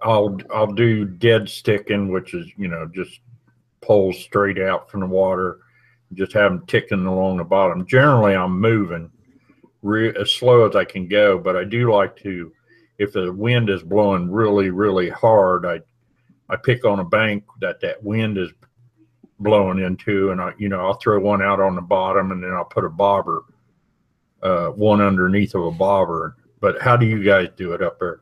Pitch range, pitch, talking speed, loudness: 95-110 Hz, 100 Hz, 195 wpm, -19 LUFS